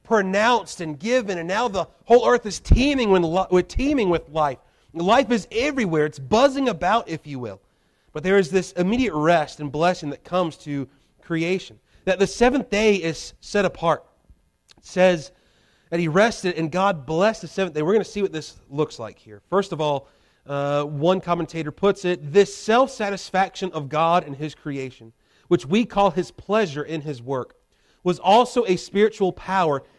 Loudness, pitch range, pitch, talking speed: -22 LUFS, 155-200 Hz, 180 Hz, 180 wpm